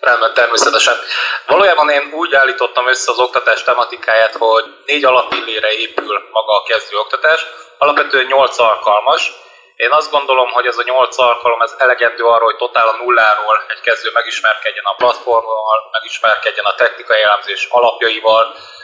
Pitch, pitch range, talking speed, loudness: 120 Hz, 115-130 Hz, 145 wpm, -12 LUFS